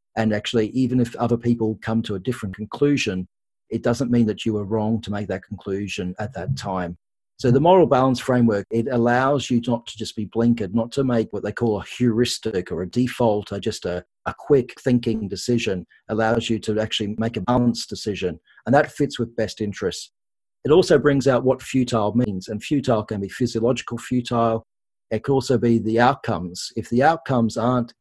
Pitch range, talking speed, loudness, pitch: 105-120 Hz, 200 wpm, -22 LUFS, 115 Hz